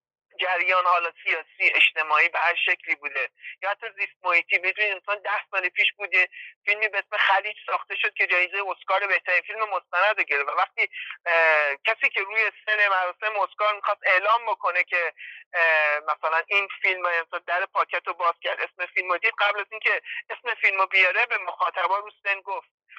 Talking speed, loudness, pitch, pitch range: 175 wpm, -23 LUFS, 195 Hz, 180-210 Hz